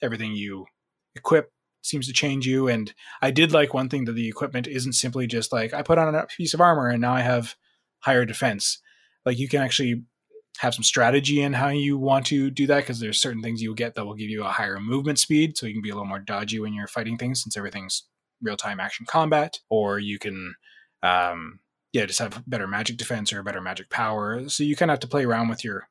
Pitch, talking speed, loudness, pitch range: 120 Hz, 240 wpm, -24 LUFS, 110-140 Hz